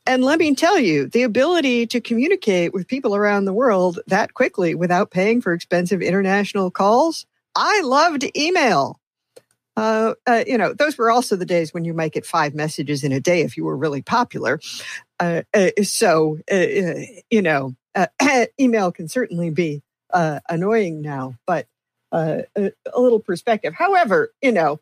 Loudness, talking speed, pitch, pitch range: -19 LUFS, 170 wpm, 200 Hz, 170-245 Hz